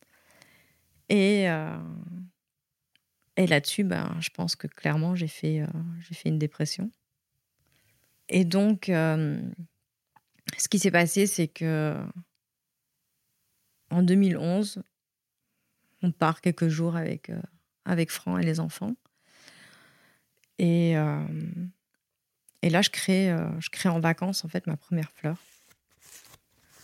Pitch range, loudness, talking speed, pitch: 160-185 Hz, -27 LUFS, 120 wpm, 170 Hz